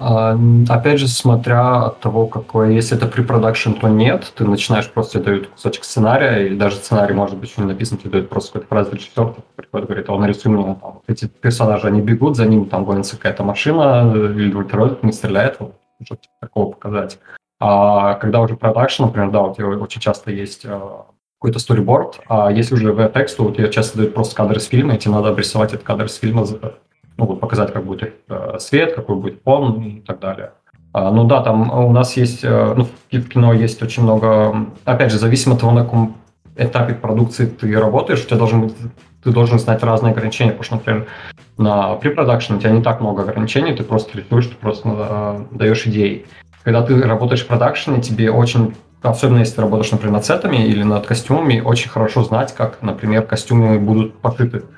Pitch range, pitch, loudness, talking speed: 105-120 Hz, 110 Hz, -16 LUFS, 200 wpm